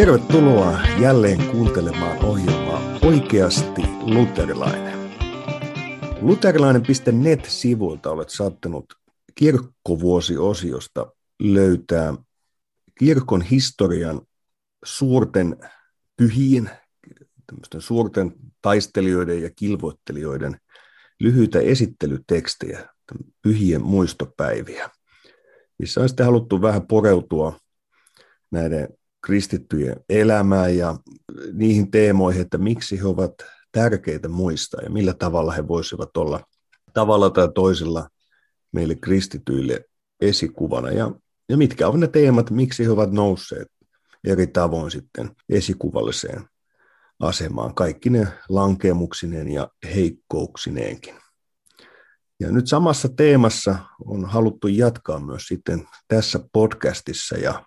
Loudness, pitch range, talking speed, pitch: -20 LUFS, 85-115 Hz, 90 wpm, 100 Hz